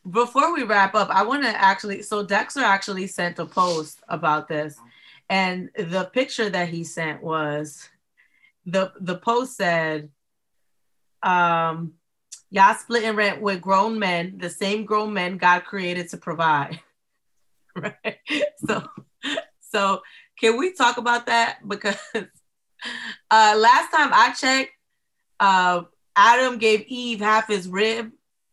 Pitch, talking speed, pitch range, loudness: 200 Hz, 135 wpm, 180-225 Hz, -21 LUFS